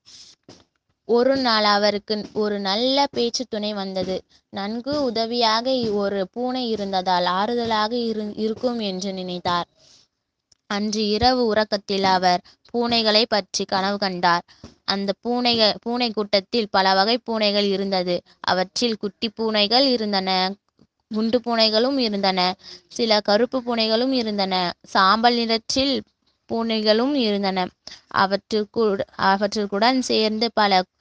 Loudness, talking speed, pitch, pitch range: -21 LUFS, 105 wpm, 215 Hz, 195-235 Hz